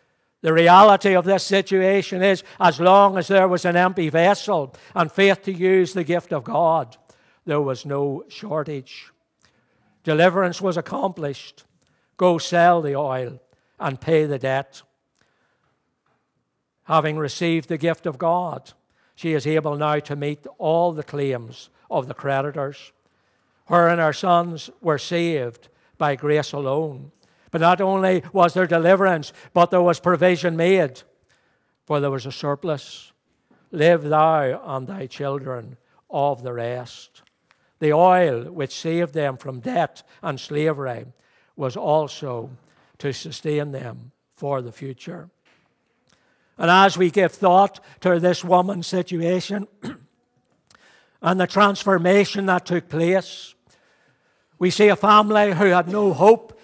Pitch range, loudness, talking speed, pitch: 140-180 Hz, -20 LUFS, 135 wpm, 165 Hz